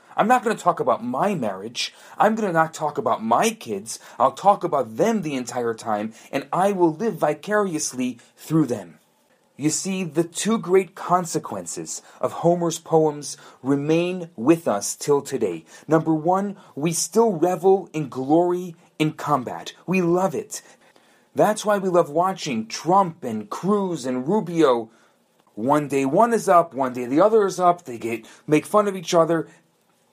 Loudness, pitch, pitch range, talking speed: -22 LUFS, 170 Hz, 150-195 Hz, 165 wpm